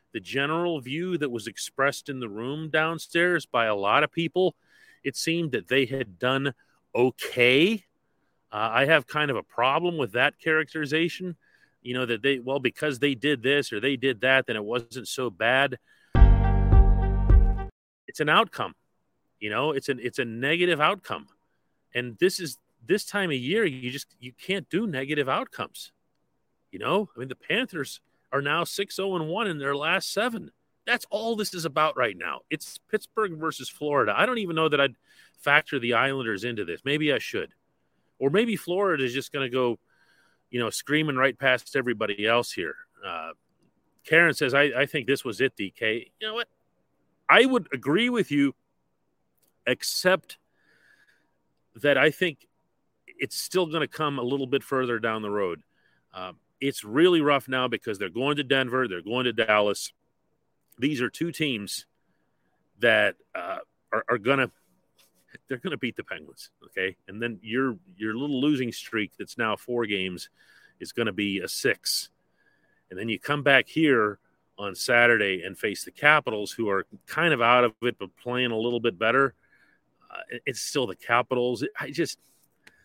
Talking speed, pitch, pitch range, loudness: 175 wpm, 135 Hz, 120-160 Hz, -25 LUFS